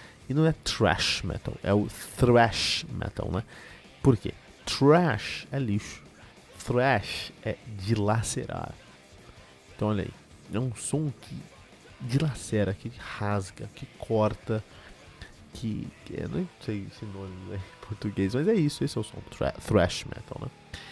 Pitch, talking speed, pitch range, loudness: 105 Hz, 140 wpm, 100-130 Hz, -28 LUFS